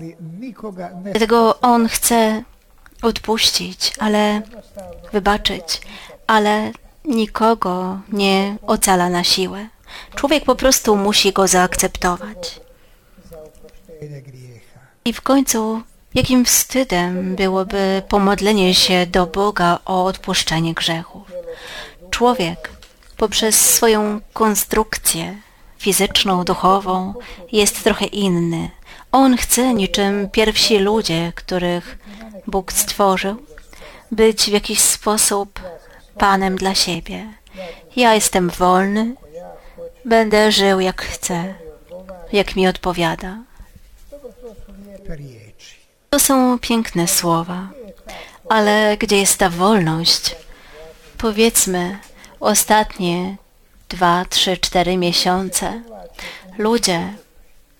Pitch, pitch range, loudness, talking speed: 195 Hz, 180-220 Hz, -16 LUFS, 85 wpm